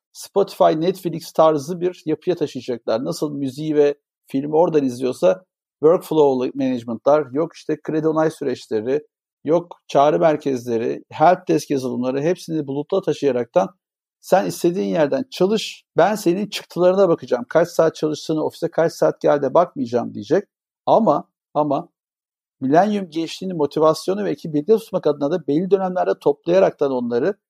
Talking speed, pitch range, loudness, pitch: 130 wpm, 145-185 Hz, -20 LUFS, 160 Hz